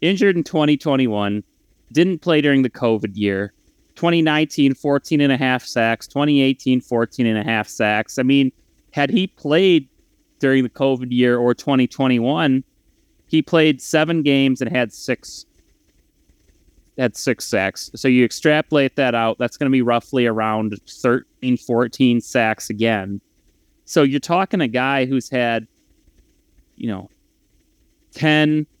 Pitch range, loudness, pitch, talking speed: 120-150 Hz, -18 LUFS, 130 Hz, 140 wpm